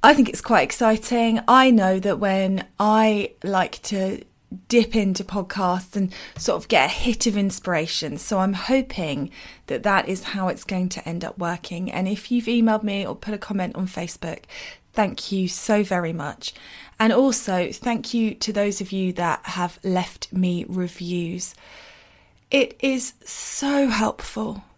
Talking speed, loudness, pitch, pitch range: 165 wpm, -22 LUFS, 200 Hz, 180-225 Hz